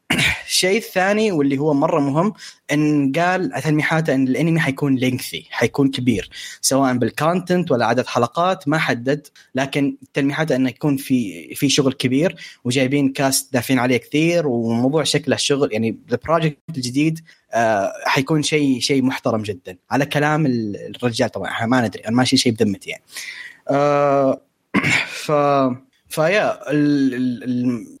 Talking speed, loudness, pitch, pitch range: 130 wpm, -19 LUFS, 140 Hz, 130-150 Hz